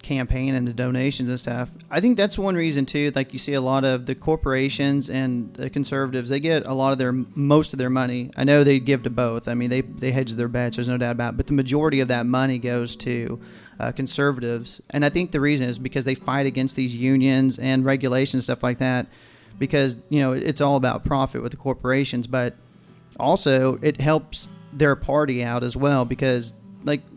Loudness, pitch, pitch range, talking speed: -22 LUFS, 130 Hz, 125-140 Hz, 220 wpm